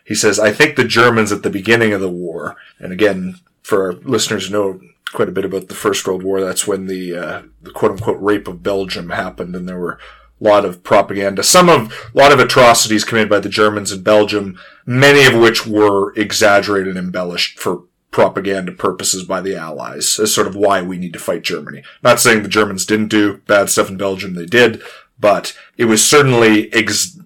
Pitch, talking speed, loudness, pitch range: 105 Hz, 210 wpm, -13 LUFS, 95-110 Hz